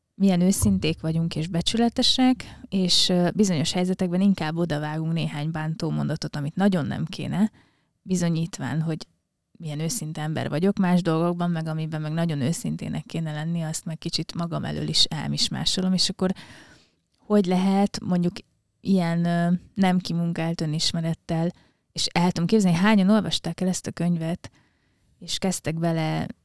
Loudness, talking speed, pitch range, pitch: -24 LUFS, 140 wpm, 160-185 Hz, 170 Hz